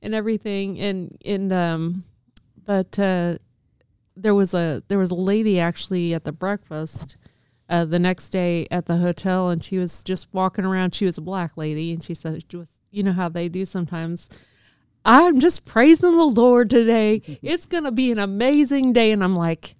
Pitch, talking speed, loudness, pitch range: 185 Hz, 185 wpm, -20 LUFS, 170-205 Hz